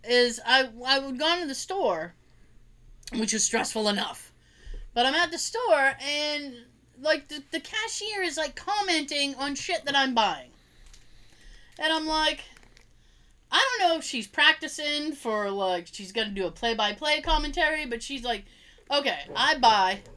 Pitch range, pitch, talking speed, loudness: 235-315 Hz, 285 Hz, 165 wpm, -26 LUFS